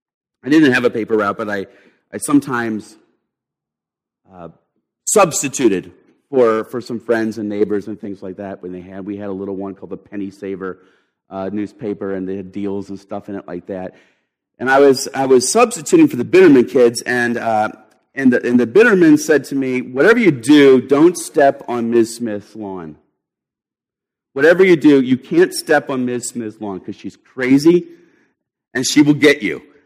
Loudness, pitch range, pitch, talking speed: -15 LUFS, 100-140 Hz, 115 Hz, 185 wpm